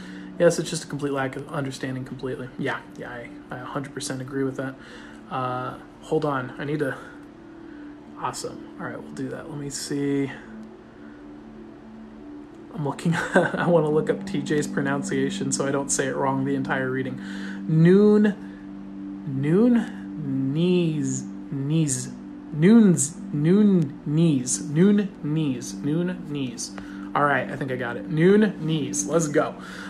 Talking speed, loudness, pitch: 145 wpm, -24 LUFS, 145 Hz